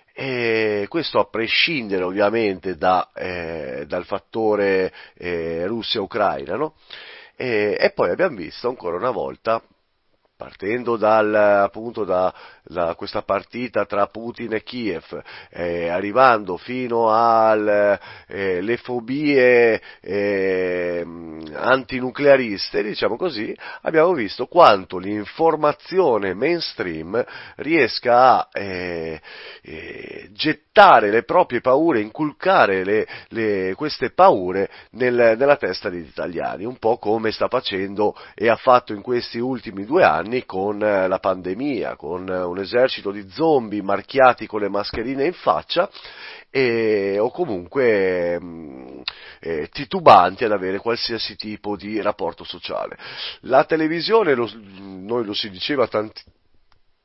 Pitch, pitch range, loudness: 105 Hz, 95-125 Hz, -20 LUFS